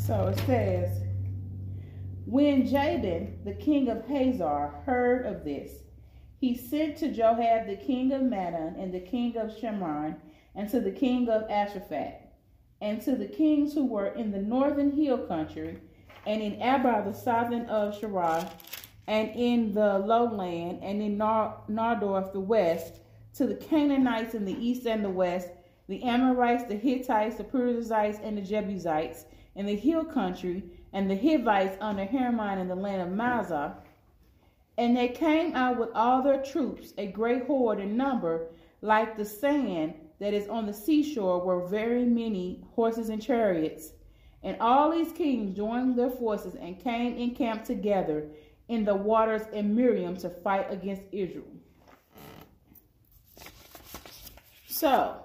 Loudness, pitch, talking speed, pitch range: -28 LUFS, 215 Hz, 150 wpm, 185-245 Hz